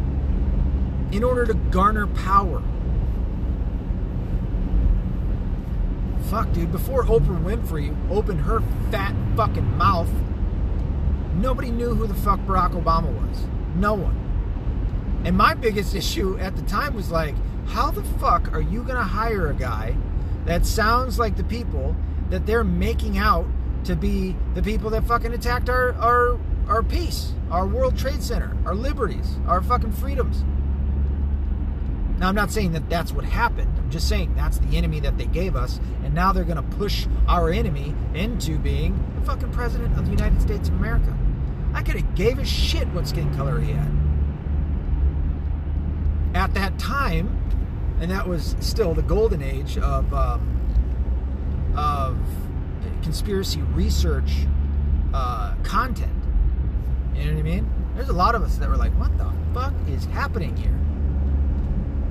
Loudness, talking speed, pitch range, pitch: -24 LUFS, 150 wpm, 70-80 Hz, 70 Hz